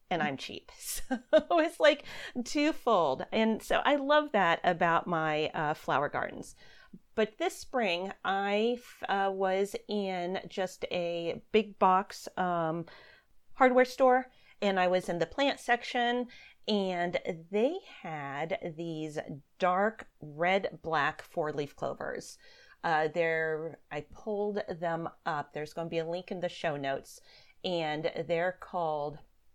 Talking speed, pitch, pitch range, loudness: 135 wpm, 185 Hz, 165-235 Hz, -31 LUFS